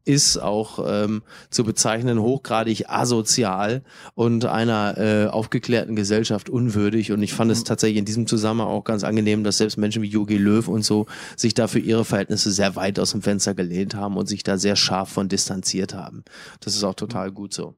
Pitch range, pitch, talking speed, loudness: 100-115 Hz, 105 Hz, 190 wpm, -21 LUFS